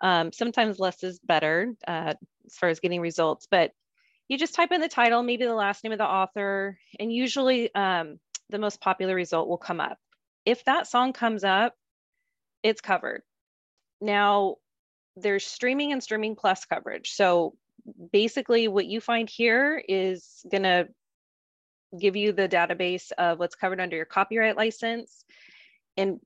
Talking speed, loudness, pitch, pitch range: 160 wpm, -26 LUFS, 205 Hz, 185-235 Hz